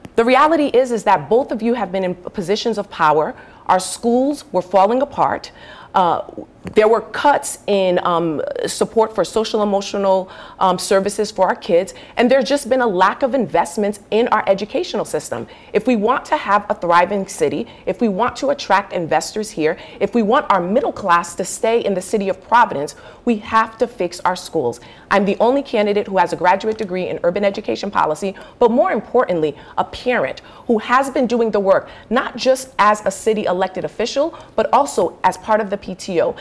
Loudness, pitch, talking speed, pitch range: -18 LUFS, 210 Hz, 195 wpm, 190-240 Hz